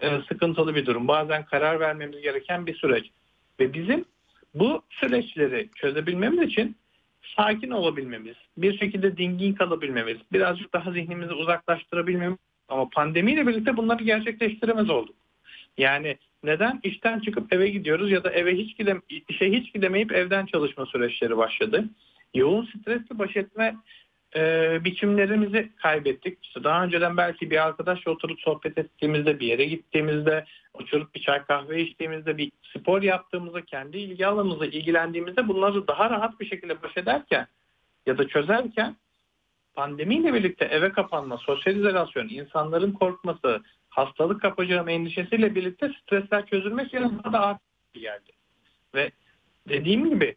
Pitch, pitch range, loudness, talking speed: 180 Hz, 155-210 Hz, -25 LUFS, 130 wpm